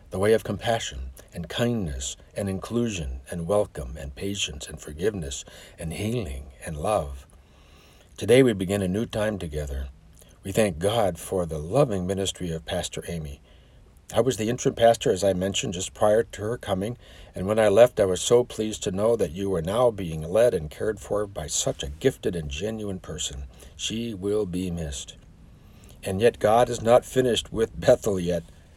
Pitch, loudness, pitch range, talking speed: 90 Hz, -25 LUFS, 75-105 Hz, 180 wpm